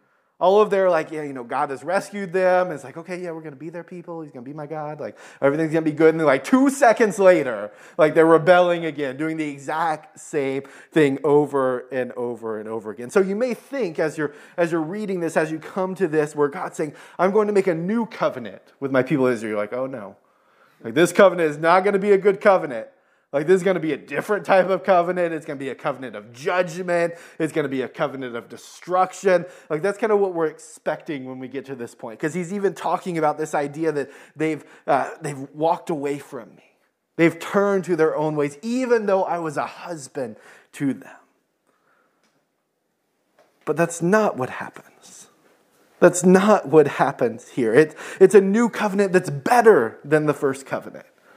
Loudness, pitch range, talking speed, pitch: -21 LUFS, 145-190 Hz, 215 wpm, 160 Hz